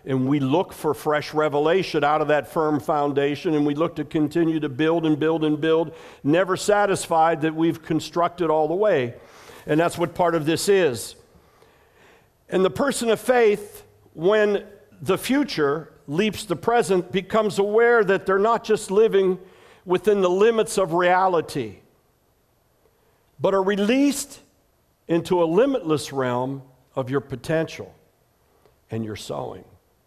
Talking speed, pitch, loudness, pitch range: 145 wpm, 170 Hz, -22 LUFS, 150-195 Hz